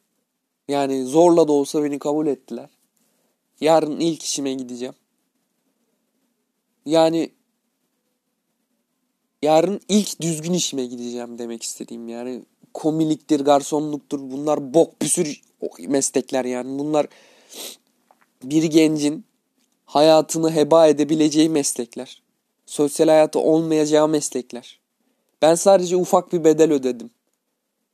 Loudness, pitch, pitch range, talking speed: -19 LUFS, 160 Hz, 145-235 Hz, 95 wpm